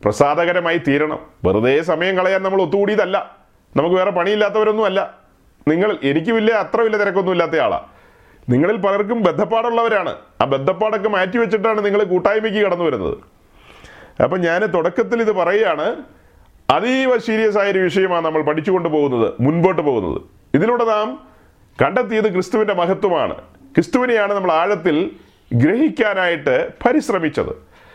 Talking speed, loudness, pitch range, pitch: 110 wpm, -17 LUFS, 180-225 Hz, 205 Hz